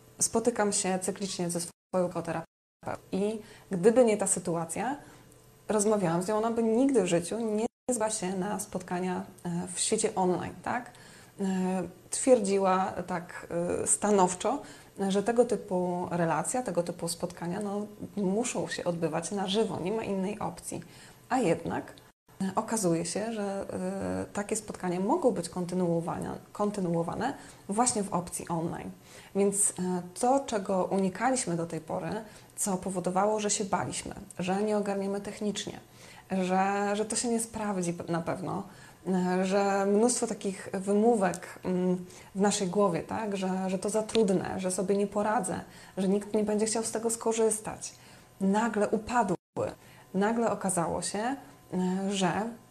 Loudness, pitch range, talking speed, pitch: -30 LUFS, 180-215 Hz, 135 wpm, 195 Hz